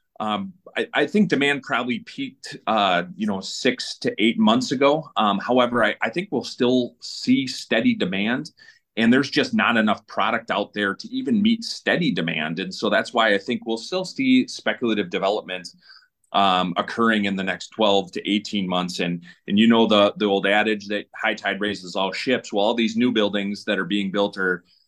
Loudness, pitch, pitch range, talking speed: -22 LUFS, 110 Hz, 100-150 Hz, 200 wpm